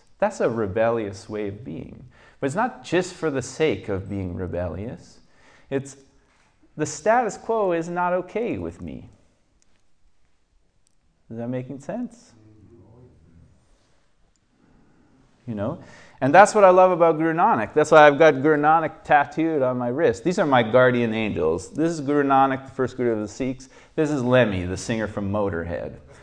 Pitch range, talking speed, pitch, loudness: 105-155 Hz, 160 wpm, 125 Hz, -21 LUFS